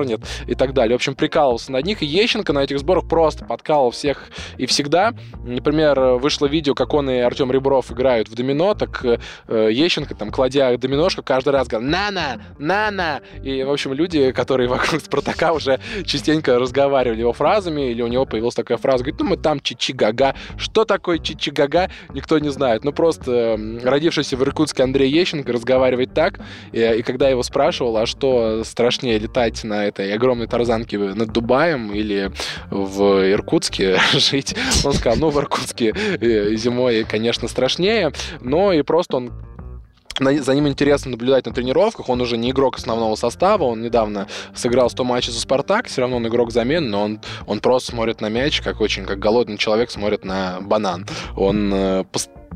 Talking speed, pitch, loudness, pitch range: 170 wpm, 125 Hz, -19 LUFS, 115-140 Hz